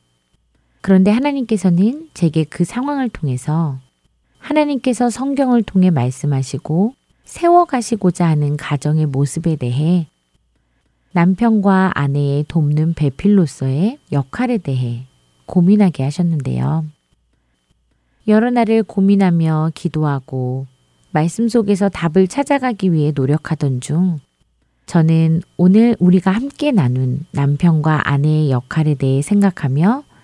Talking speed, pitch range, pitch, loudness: 260 characters per minute, 140-200 Hz, 160 Hz, -16 LUFS